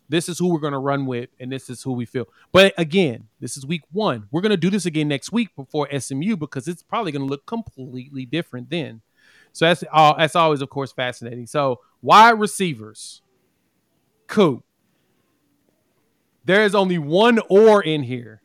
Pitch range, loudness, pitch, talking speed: 130-180 Hz, -19 LUFS, 155 Hz, 190 wpm